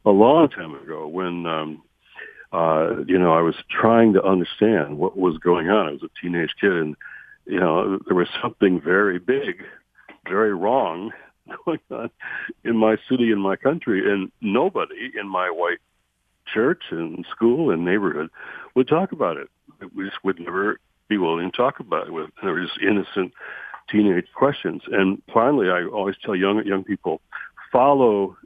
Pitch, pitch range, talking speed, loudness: 95 Hz, 85-110 Hz, 170 wpm, -21 LUFS